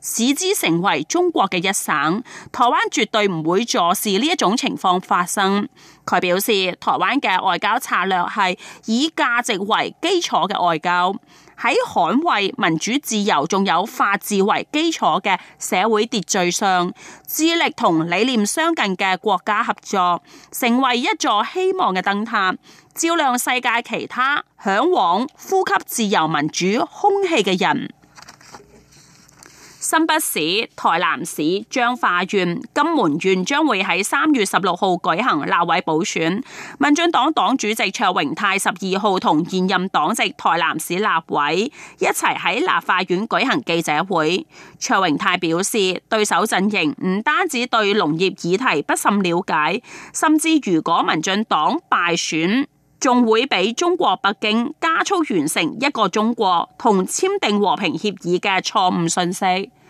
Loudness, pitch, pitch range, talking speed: -18 LUFS, 210 Hz, 185-290 Hz, 220 characters per minute